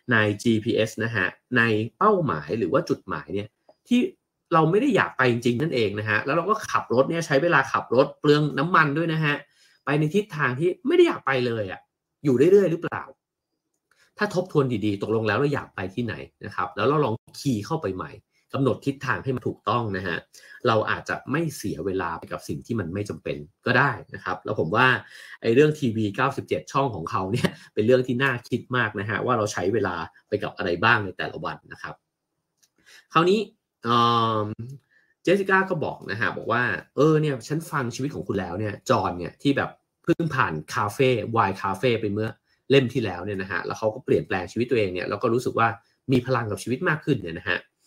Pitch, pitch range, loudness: 130 Hz, 105-150 Hz, -24 LUFS